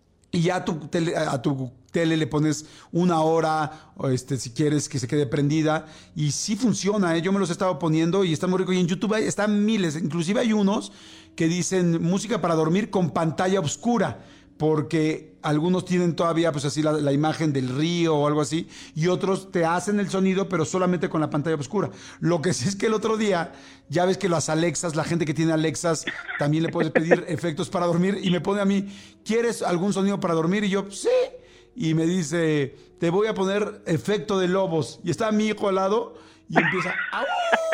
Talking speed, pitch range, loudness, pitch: 210 wpm, 155-195 Hz, -24 LUFS, 170 Hz